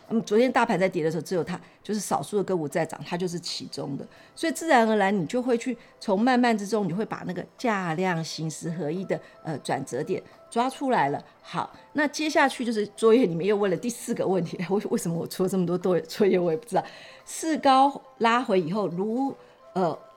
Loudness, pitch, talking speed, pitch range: -26 LUFS, 205 Hz, 325 characters per minute, 180-240 Hz